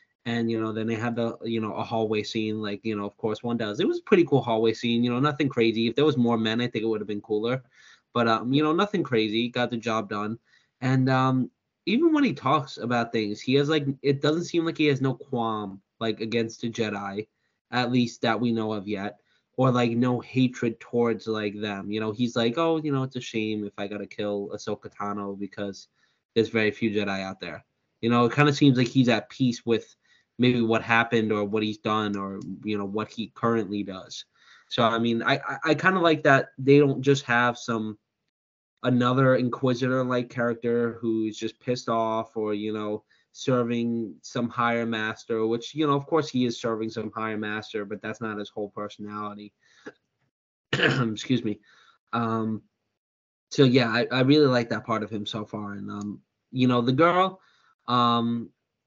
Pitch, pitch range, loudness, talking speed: 115 Hz, 110-125 Hz, -26 LUFS, 210 wpm